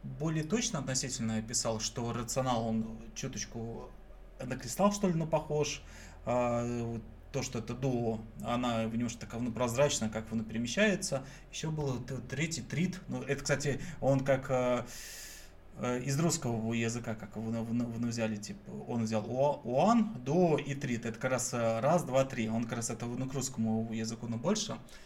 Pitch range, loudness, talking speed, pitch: 115-140 Hz, -33 LUFS, 175 wpm, 120 Hz